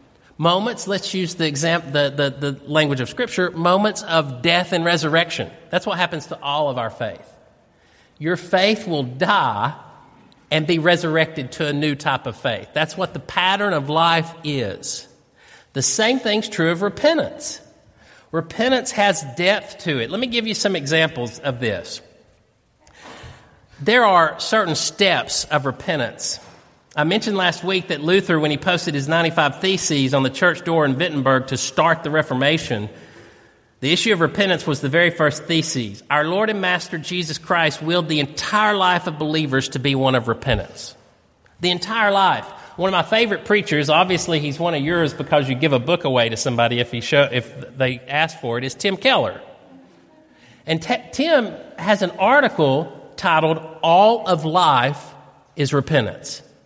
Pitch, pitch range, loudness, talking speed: 165 Hz, 145-185 Hz, -19 LUFS, 170 wpm